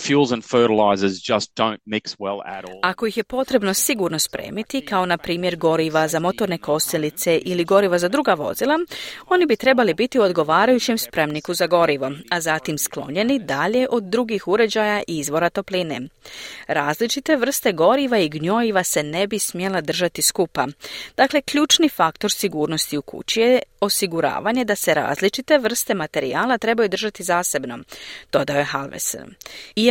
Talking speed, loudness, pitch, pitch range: 135 wpm, -20 LUFS, 180 Hz, 155-225 Hz